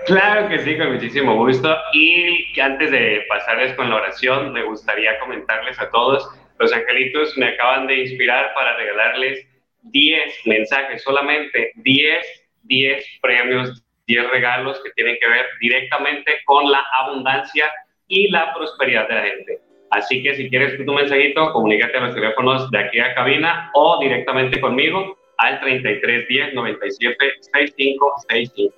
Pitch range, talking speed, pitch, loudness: 130-155 Hz, 150 wpm, 135 Hz, -16 LUFS